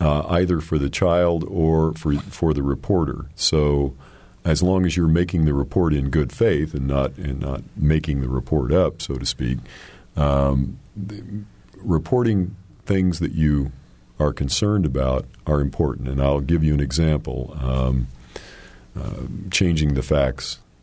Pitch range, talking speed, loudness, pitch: 70-90 Hz, 155 wpm, -22 LUFS, 75 Hz